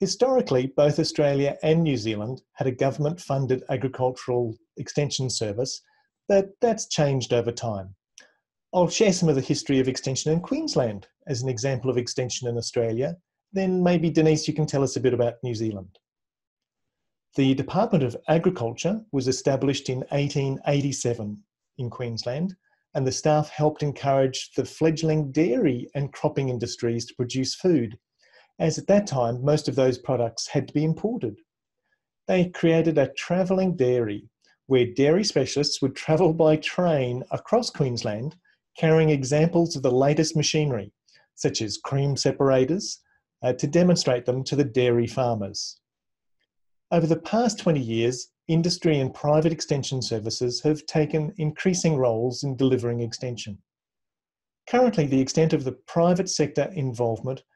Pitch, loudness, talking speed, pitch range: 140 Hz, -24 LUFS, 145 wpm, 125-160 Hz